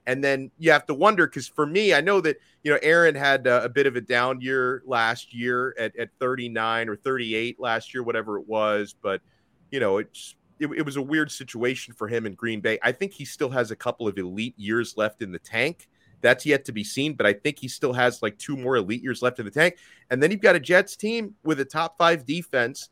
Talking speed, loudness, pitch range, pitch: 250 wpm, -24 LUFS, 115-150 Hz, 130 Hz